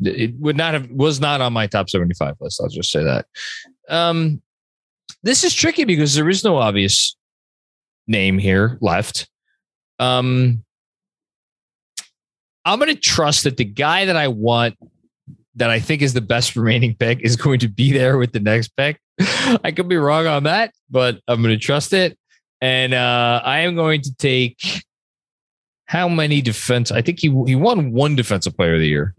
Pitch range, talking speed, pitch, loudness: 115-155 Hz, 175 wpm, 130 Hz, -17 LUFS